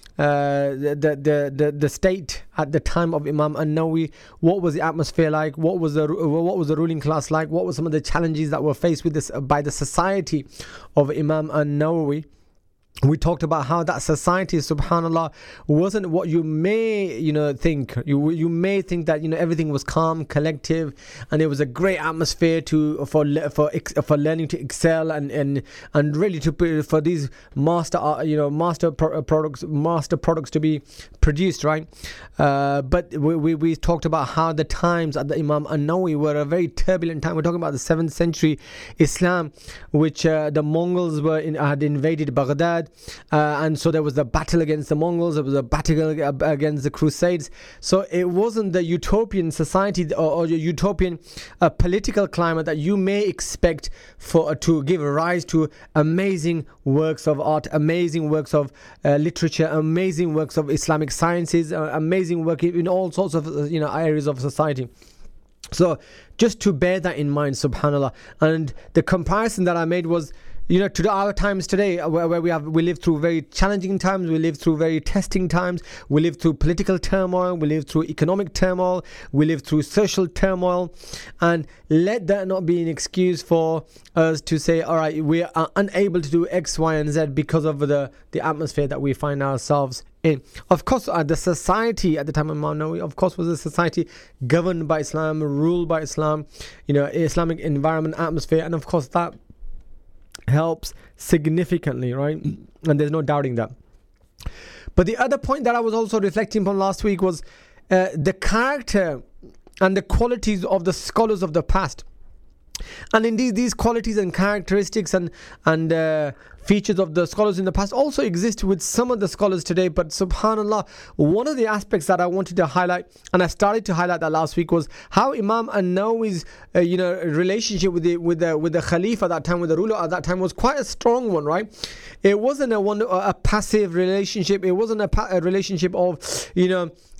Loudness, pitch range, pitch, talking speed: -21 LUFS, 155-185 Hz, 165 Hz, 190 wpm